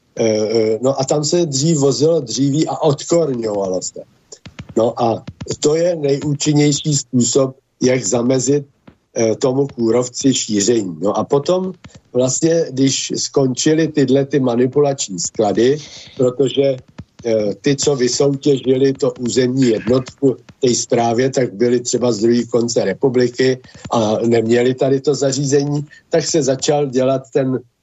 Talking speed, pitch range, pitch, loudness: 125 wpm, 120-145 Hz, 135 Hz, -16 LUFS